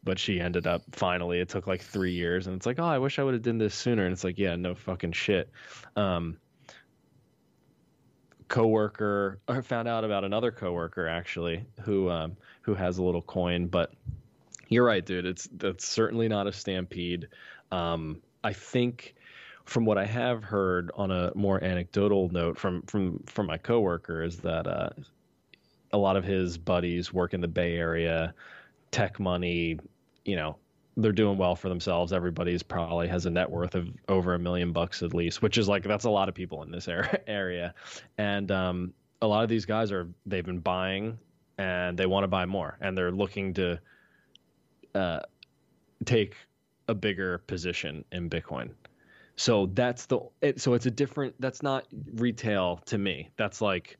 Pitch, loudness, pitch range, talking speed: 95 Hz, -30 LUFS, 90-105 Hz, 180 wpm